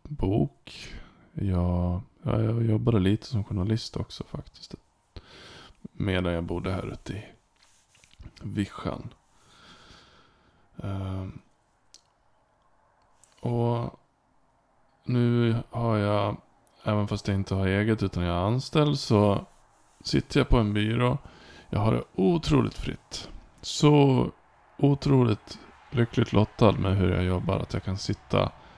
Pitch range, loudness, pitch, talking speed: 95-120 Hz, -27 LUFS, 105 Hz, 115 wpm